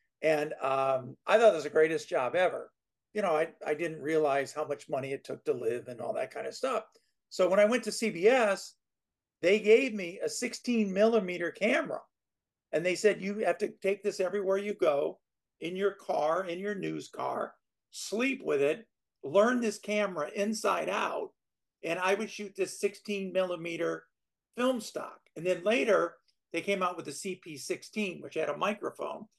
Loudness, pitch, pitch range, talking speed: -31 LUFS, 195 Hz, 165-210 Hz, 185 wpm